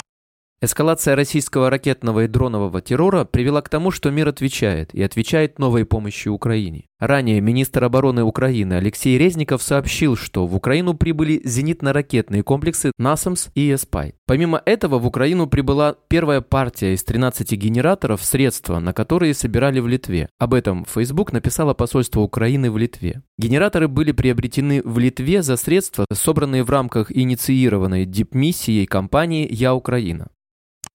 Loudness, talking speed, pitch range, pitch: -18 LUFS, 140 wpm, 110-145 Hz, 130 Hz